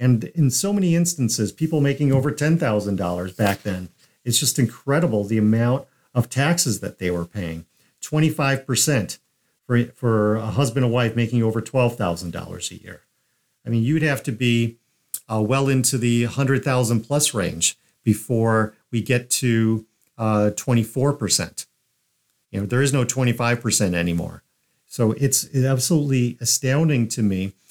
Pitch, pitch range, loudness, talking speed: 120 Hz, 110-135 Hz, -21 LUFS, 155 wpm